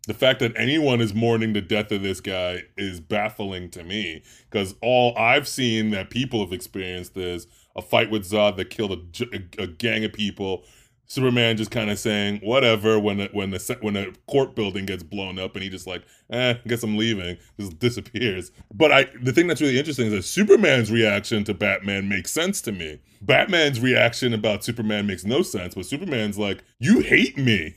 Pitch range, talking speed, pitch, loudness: 100-120 Hz, 200 wpm, 105 Hz, -22 LUFS